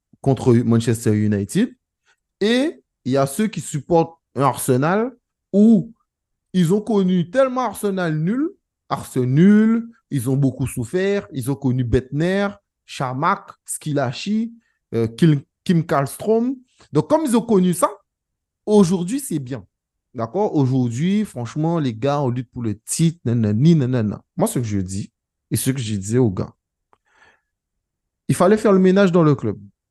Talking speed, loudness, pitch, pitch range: 150 wpm, -19 LUFS, 155 Hz, 125-200 Hz